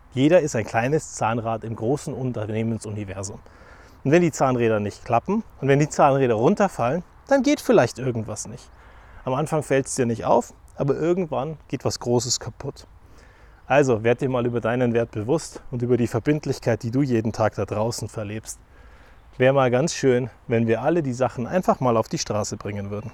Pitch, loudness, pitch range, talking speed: 120 Hz, -23 LUFS, 110-140 Hz, 185 wpm